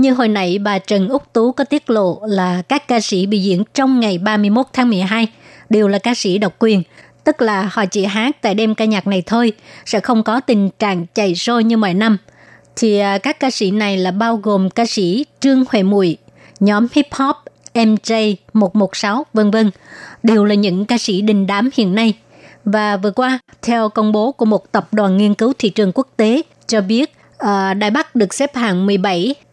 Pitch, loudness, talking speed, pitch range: 215 Hz, -15 LUFS, 205 wpm, 200-235 Hz